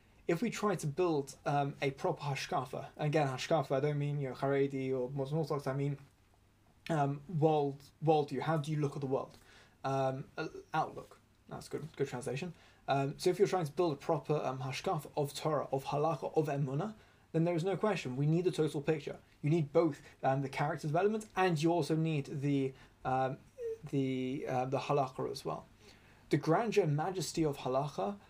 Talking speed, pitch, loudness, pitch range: 195 wpm, 145 Hz, -35 LUFS, 135-165 Hz